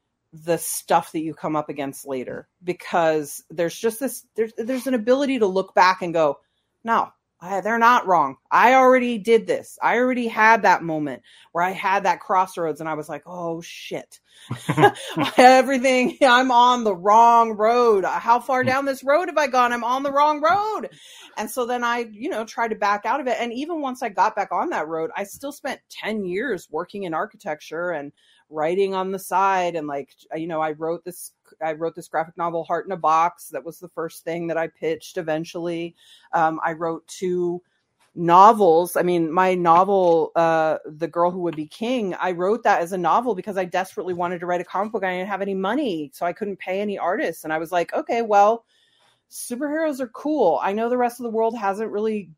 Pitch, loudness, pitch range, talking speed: 190 Hz, -21 LUFS, 165-235 Hz, 210 wpm